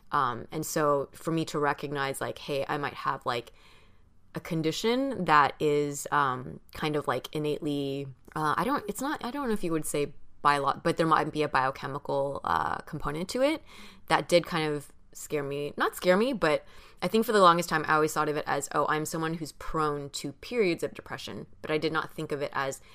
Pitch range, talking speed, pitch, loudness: 145-165 Hz, 220 wpm, 150 Hz, -29 LUFS